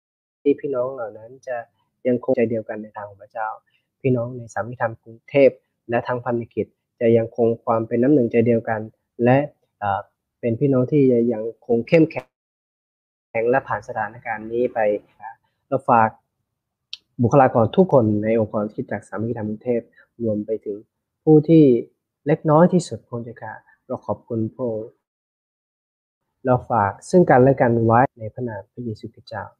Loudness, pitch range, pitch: -20 LUFS, 110-130 Hz, 115 Hz